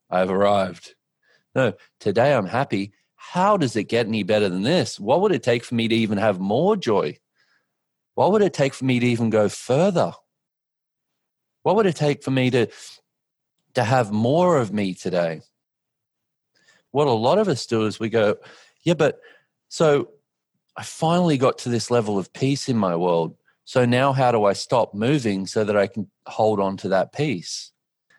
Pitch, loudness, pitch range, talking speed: 115 Hz, -21 LUFS, 100-130 Hz, 185 wpm